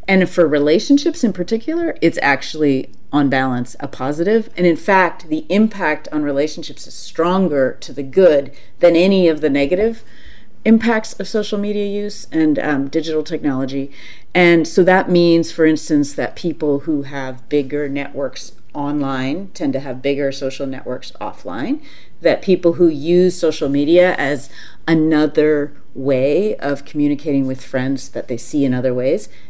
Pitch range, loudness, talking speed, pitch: 140-185 Hz, -17 LUFS, 155 wpm, 155 Hz